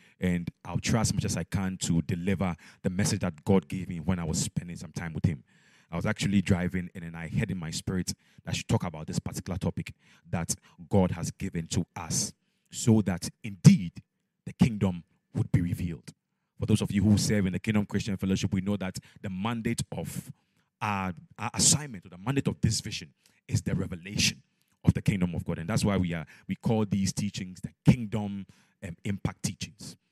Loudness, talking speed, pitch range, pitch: -29 LUFS, 210 wpm, 90-105 Hz, 95 Hz